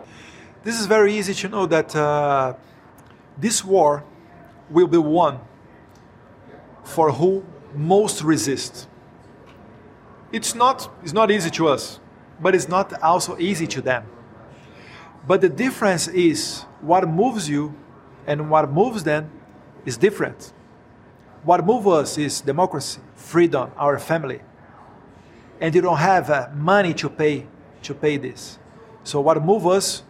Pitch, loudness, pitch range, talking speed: 160 Hz, -20 LUFS, 140-185 Hz, 135 wpm